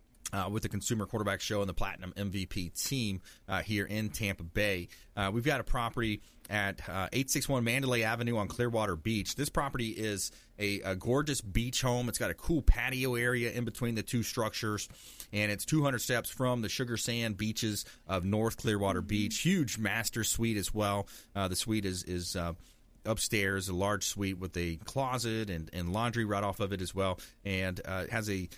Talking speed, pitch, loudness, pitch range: 195 wpm, 105 Hz, -33 LUFS, 95-115 Hz